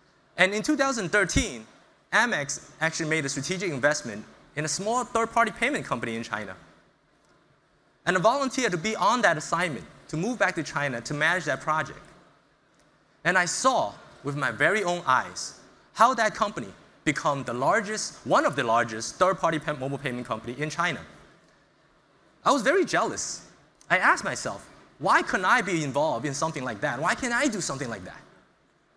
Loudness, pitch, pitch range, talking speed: -26 LUFS, 160 Hz, 140-215 Hz, 170 wpm